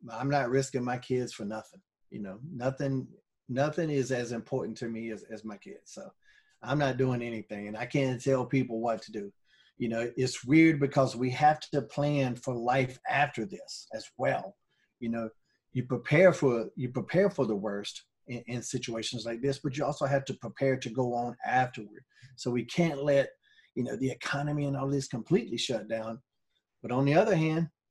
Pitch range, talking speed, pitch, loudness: 120-140 Hz, 200 wpm, 130 Hz, -30 LUFS